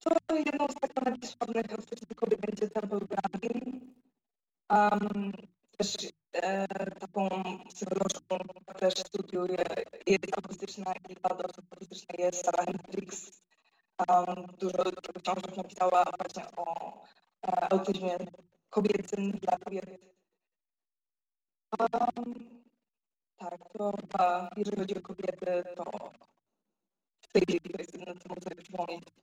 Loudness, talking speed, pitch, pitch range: -33 LUFS, 105 wpm, 195 Hz, 180-215 Hz